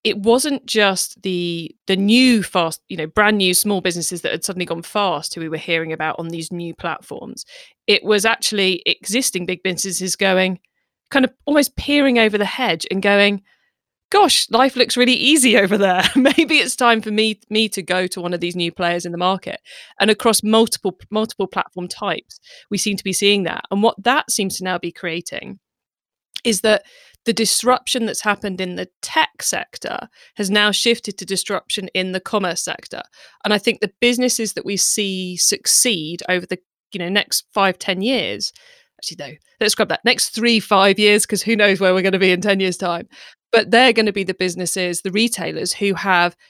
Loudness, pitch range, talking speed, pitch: -17 LUFS, 185-225 Hz, 200 wpm, 200 Hz